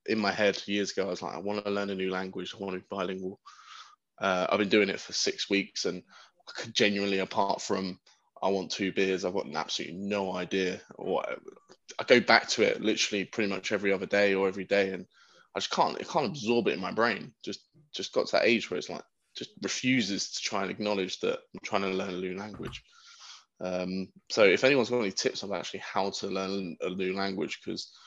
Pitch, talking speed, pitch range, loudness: 95 Hz, 235 wpm, 95-105 Hz, -29 LUFS